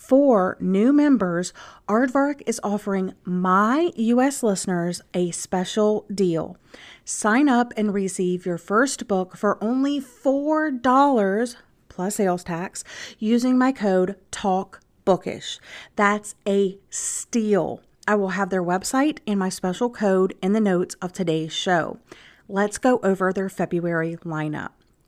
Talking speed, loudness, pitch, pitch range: 125 wpm, -22 LUFS, 200 Hz, 185-240 Hz